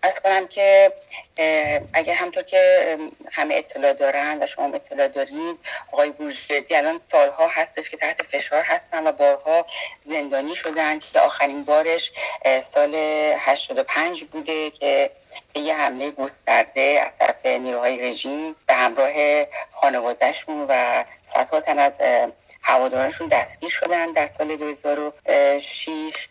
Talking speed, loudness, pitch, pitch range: 120 wpm, -20 LUFS, 155 Hz, 140-175 Hz